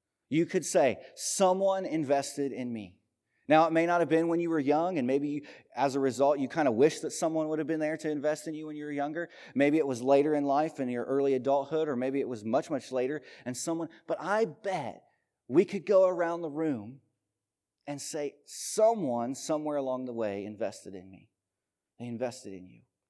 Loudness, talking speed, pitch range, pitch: -30 LUFS, 215 wpm, 125-160 Hz, 145 Hz